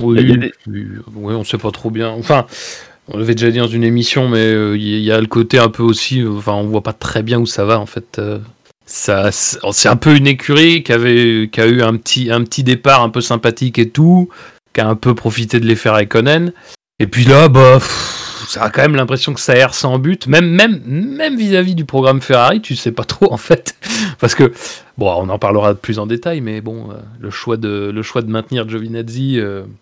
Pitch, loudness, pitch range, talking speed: 120 Hz, -12 LUFS, 110-135 Hz, 230 wpm